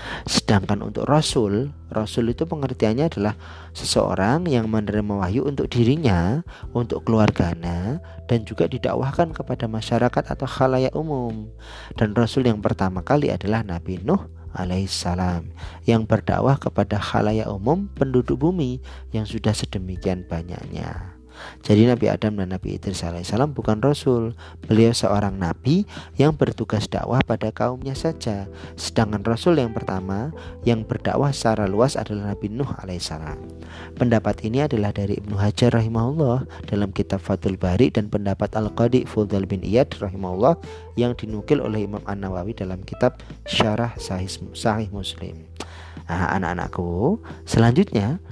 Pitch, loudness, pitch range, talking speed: 105 Hz, -22 LUFS, 95-120 Hz, 130 wpm